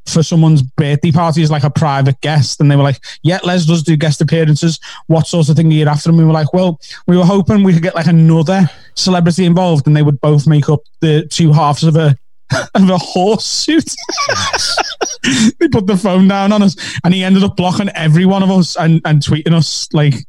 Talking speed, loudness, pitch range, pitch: 230 wpm, -11 LUFS, 150-185 Hz, 165 Hz